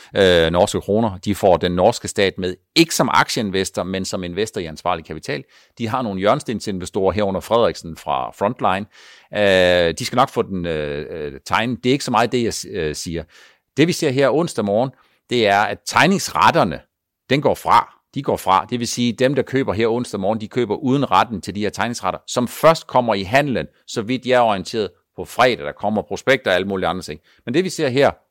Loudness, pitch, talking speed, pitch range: -19 LUFS, 110 Hz, 215 wpm, 95-125 Hz